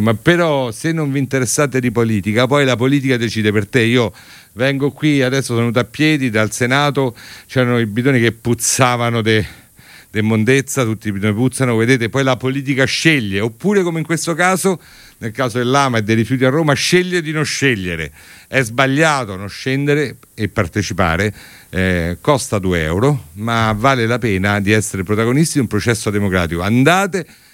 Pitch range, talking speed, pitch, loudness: 110-140 Hz, 175 wpm, 125 Hz, -16 LUFS